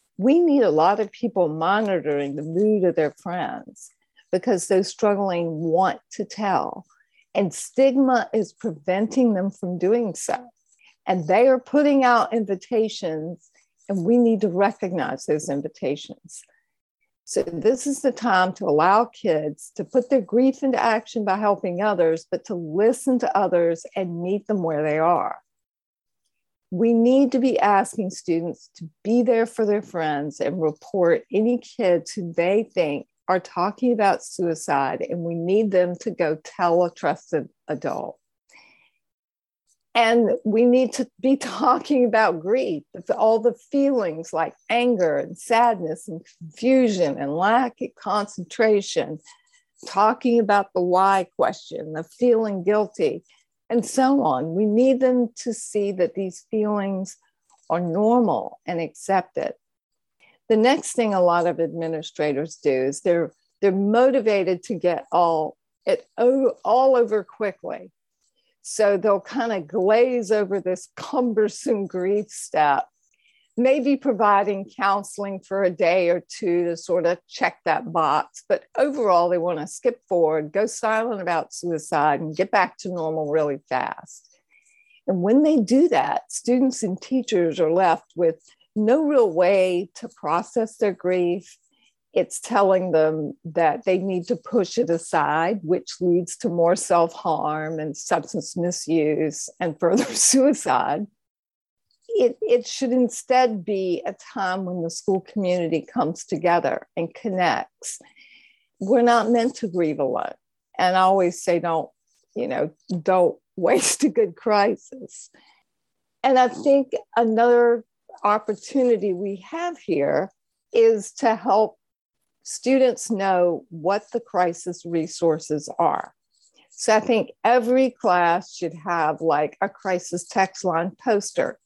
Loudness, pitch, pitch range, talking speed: -22 LUFS, 200 Hz, 175-240 Hz, 140 wpm